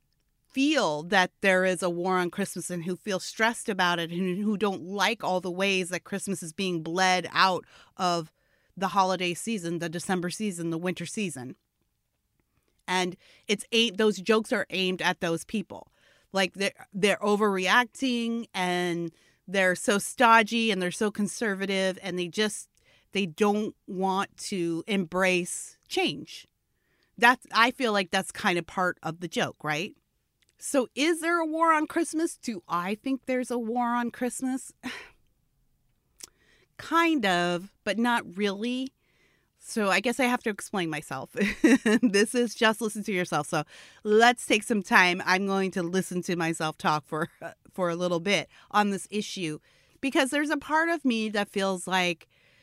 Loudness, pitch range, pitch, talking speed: -27 LUFS, 180-230 Hz, 195 Hz, 165 wpm